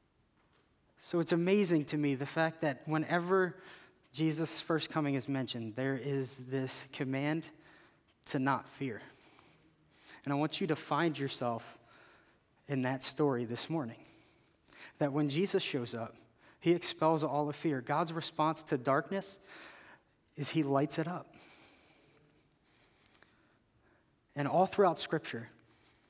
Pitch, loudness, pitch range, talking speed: 150 Hz, -34 LUFS, 135-165 Hz, 130 wpm